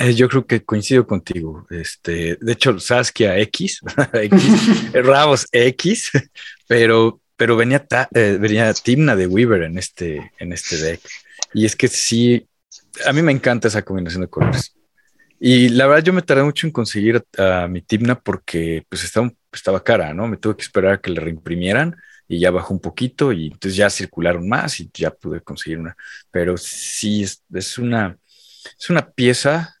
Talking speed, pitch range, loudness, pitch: 180 wpm, 90-125 Hz, -17 LUFS, 115 Hz